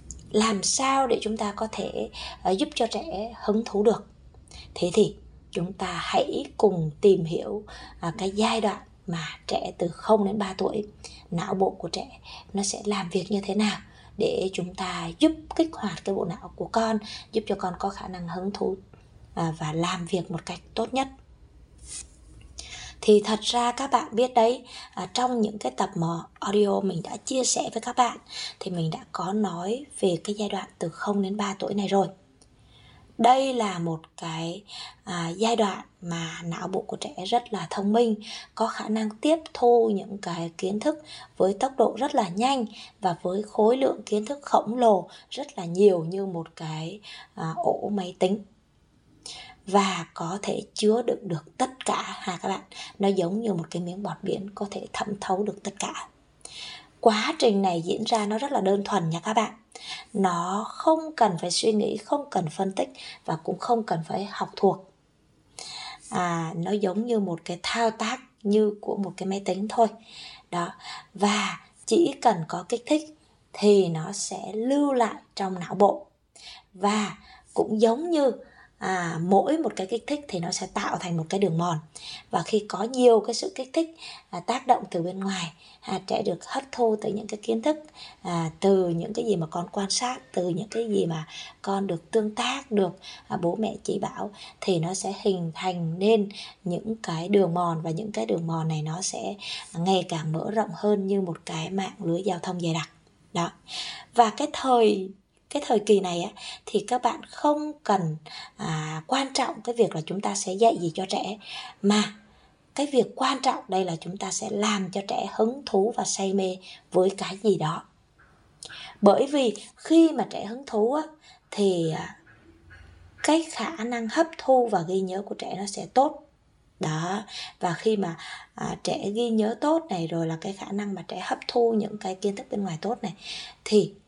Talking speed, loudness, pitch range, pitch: 195 wpm, -26 LUFS, 185-235 Hz, 205 Hz